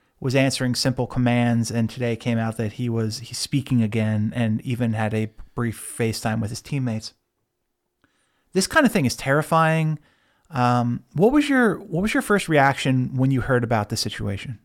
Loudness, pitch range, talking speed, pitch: -22 LUFS, 115-140 Hz, 180 wpm, 120 Hz